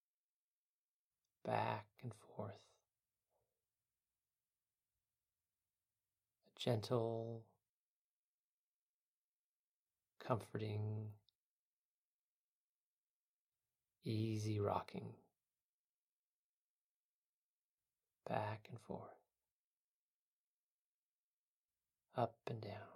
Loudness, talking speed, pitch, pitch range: -45 LUFS, 35 wpm, 105 Hz, 100-110 Hz